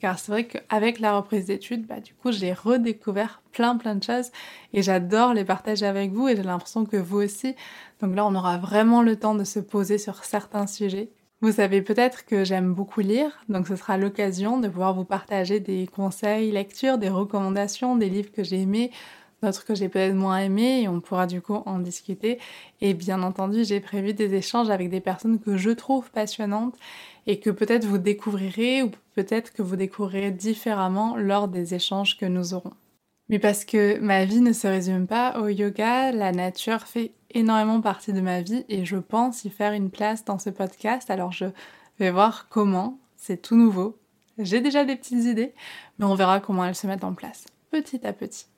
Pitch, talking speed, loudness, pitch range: 205 Hz, 205 wpm, -24 LUFS, 195-225 Hz